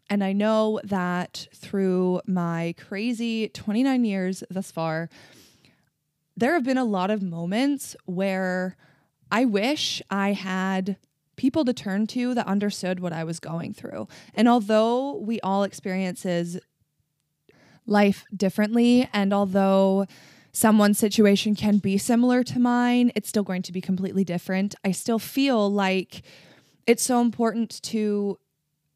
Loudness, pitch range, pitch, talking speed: -24 LUFS, 180-220 Hz, 195 Hz, 135 wpm